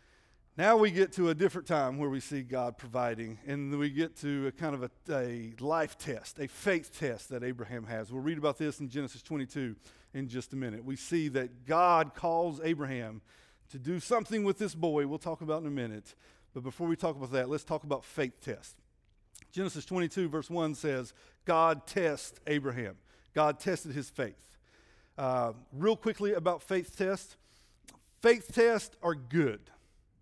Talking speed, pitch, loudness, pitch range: 180 wpm, 145 Hz, -33 LUFS, 125-170 Hz